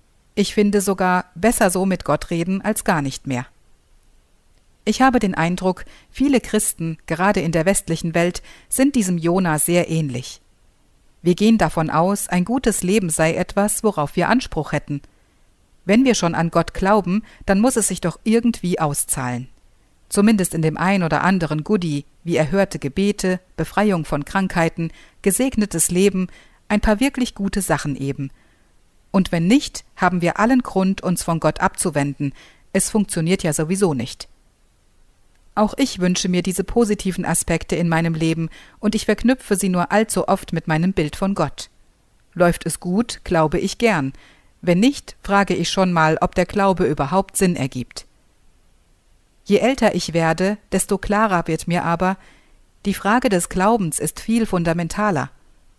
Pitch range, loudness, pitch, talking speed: 160-205 Hz, -19 LUFS, 180 Hz, 160 wpm